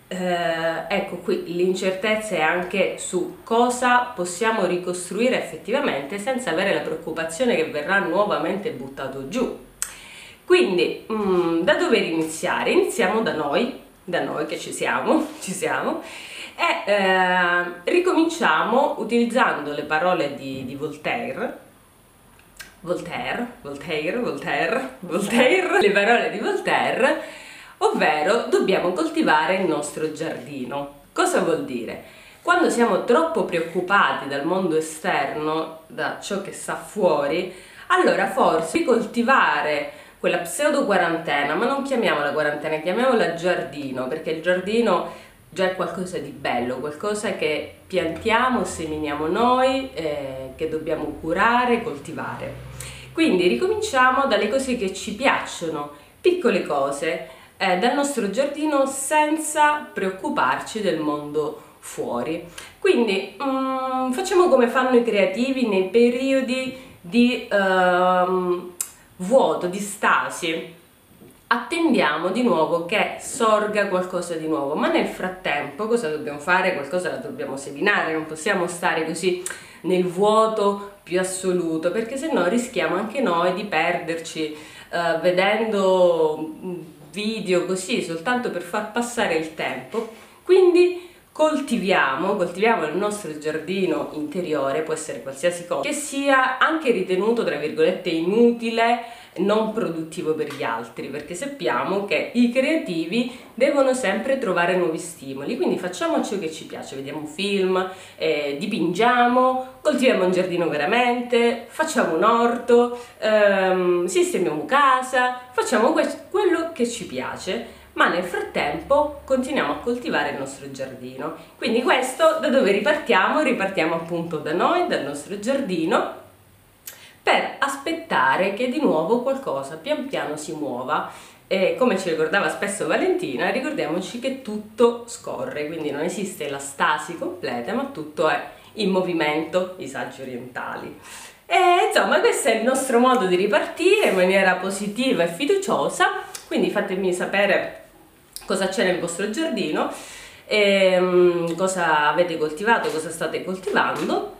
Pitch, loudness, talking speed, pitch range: 195 Hz, -22 LUFS, 125 wpm, 165-250 Hz